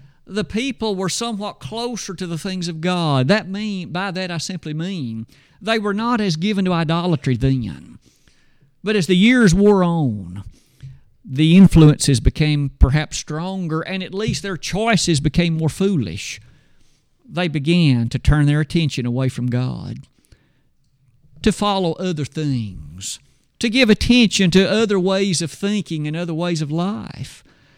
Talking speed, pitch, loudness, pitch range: 150 wpm, 170 Hz, -18 LUFS, 140-195 Hz